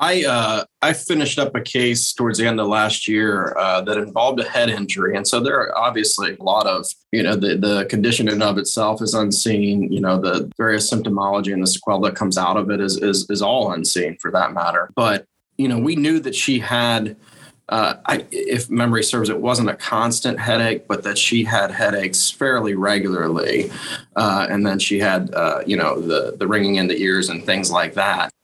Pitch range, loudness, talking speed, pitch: 100-120 Hz, -19 LUFS, 215 wpm, 105 Hz